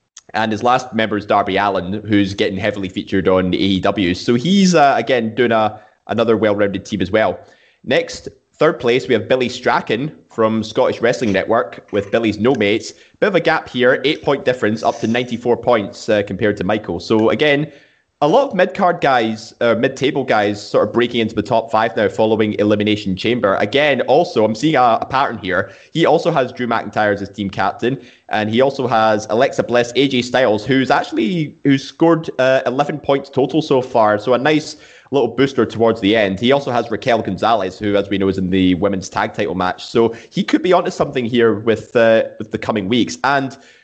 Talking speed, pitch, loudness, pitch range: 205 wpm, 115 Hz, -16 LUFS, 105-130 Hz